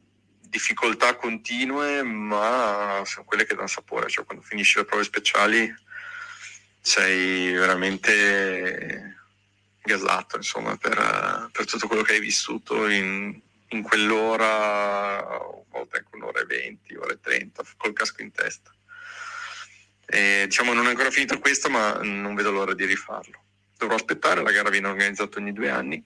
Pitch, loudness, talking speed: 110 Hz, -23 LUFS, 145 wpm